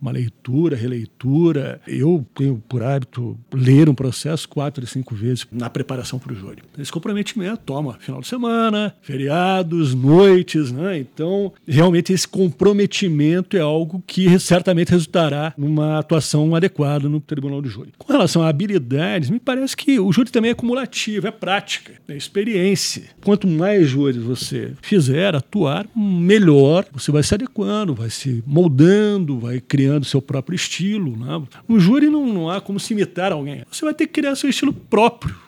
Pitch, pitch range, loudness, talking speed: 165 Hz, 140-195 Hz, -18 LUFS, 170 wpm